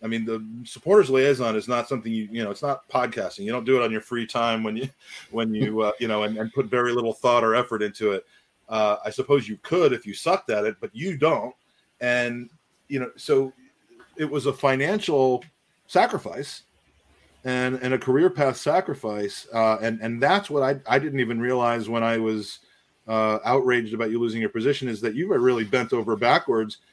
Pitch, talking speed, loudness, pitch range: 120 Hz, 210 wpm, -24 LUFS, 110-130 Hz